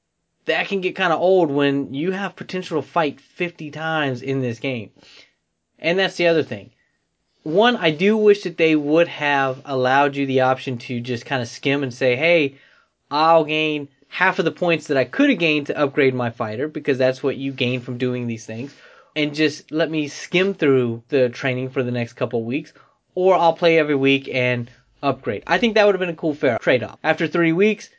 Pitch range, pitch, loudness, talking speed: 130-170 Hz, 145 Hz, -20 LUFS, 215 wpm